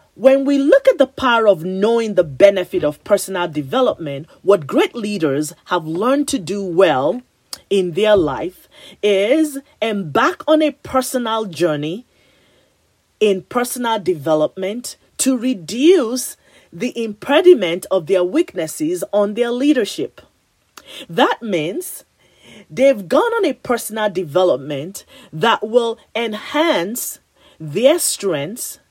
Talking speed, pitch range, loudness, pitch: 115 wpm, 185-270 Hz, -17 LUFS, 220 Hz